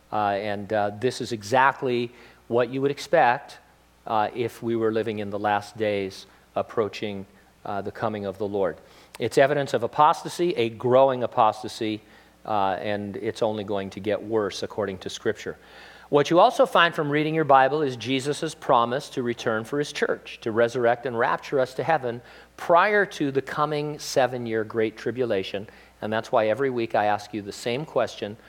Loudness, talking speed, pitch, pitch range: -24 LUFS, 180 wpm, 115 Hz, 105-140 Hz